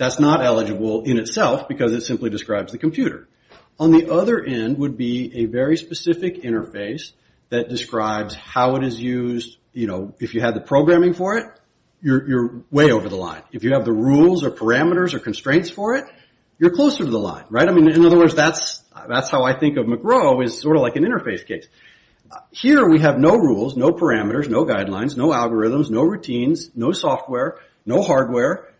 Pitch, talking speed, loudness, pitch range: 130 Hz, 200 wpm, -18 LUFS, 115-165 Hz